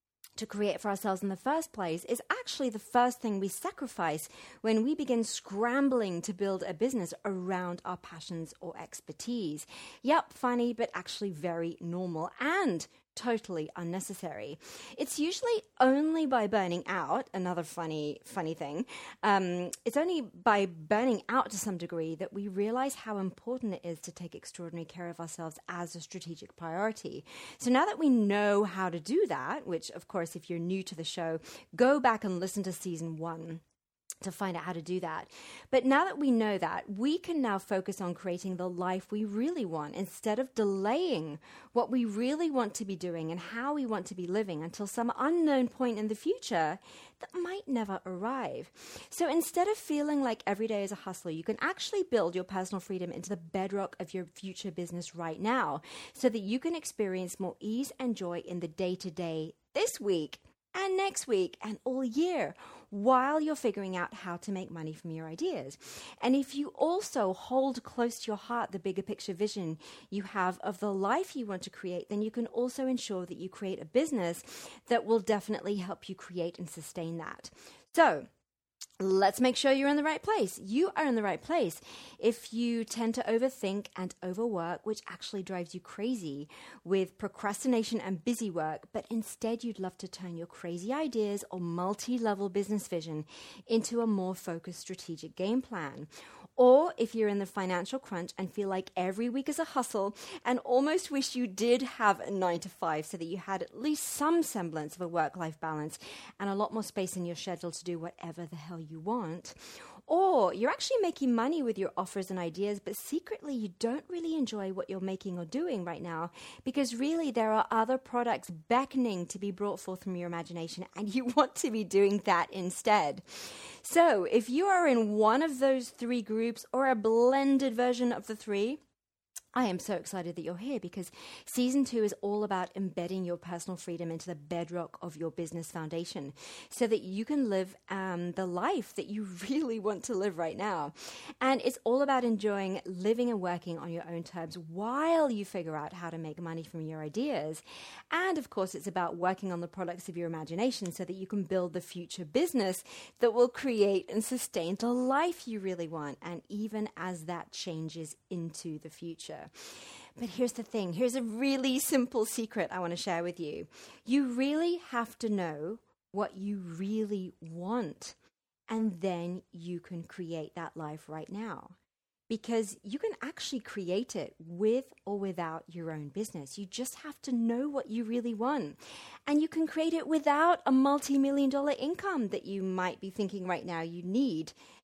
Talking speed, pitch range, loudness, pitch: 190 wpm, 175-250 Hz, -33 LUFS, 205 Hz